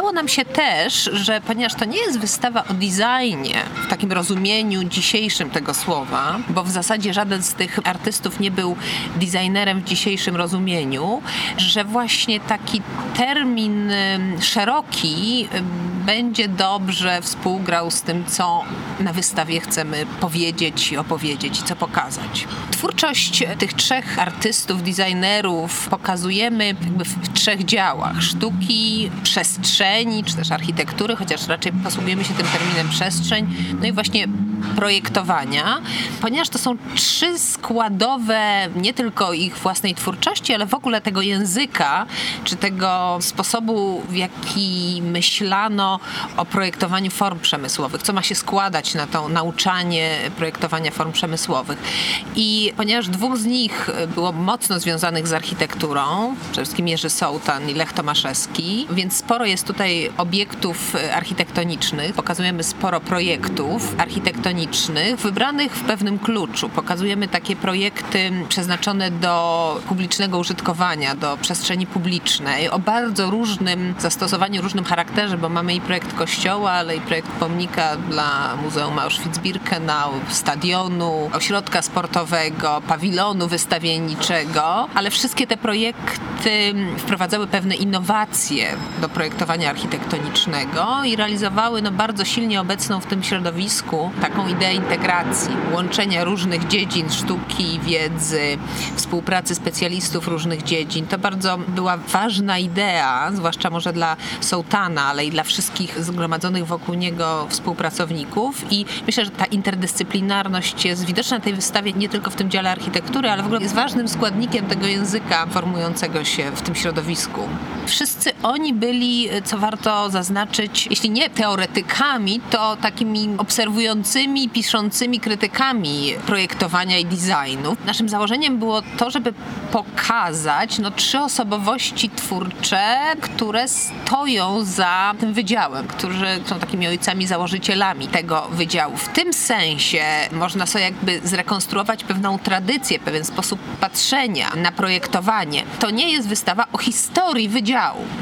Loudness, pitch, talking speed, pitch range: -19 LUFS, 195 Hz, 125 wpm, 175-215 Hz